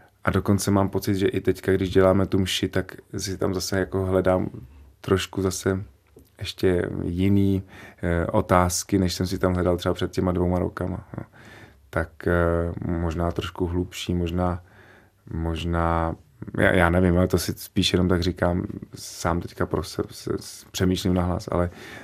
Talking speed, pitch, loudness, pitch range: 155 wpm, 95 Hz, -24 LUFS, 90-95 Hz